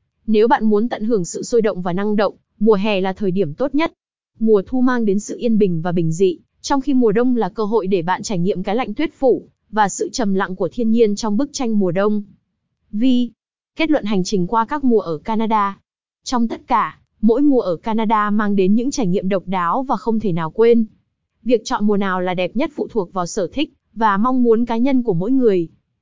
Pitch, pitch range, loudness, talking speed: 220 Hz, 195-240 Hz, -18 LUFS, 240 wpm